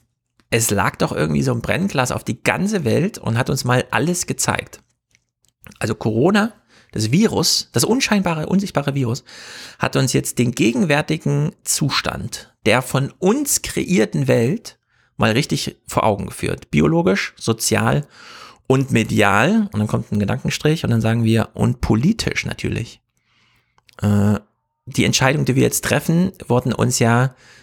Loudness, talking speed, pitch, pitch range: -18 LUFS, 145 wpm, 125 Hz, 110-170 Hz